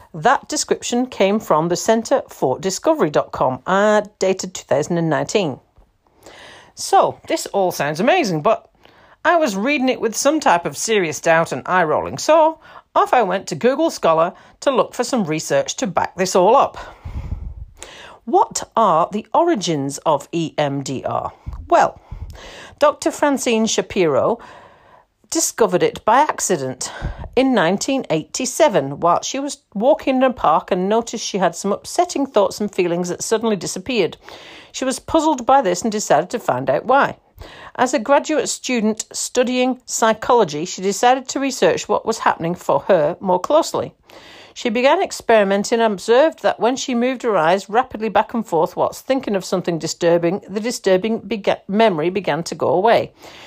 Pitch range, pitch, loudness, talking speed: 185-265 Hz, 225 Hz, -18 LUFS, 155 wpm